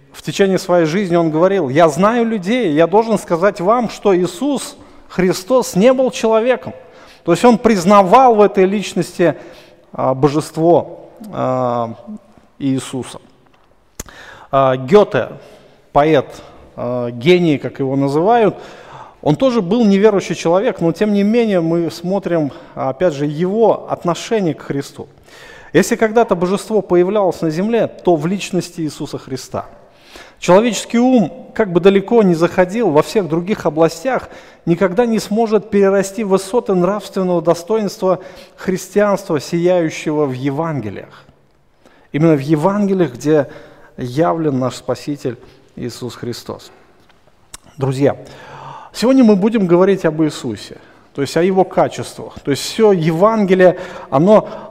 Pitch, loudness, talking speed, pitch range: 180 Hz, -15 LUFS, 120 wpm, 155-205 Hz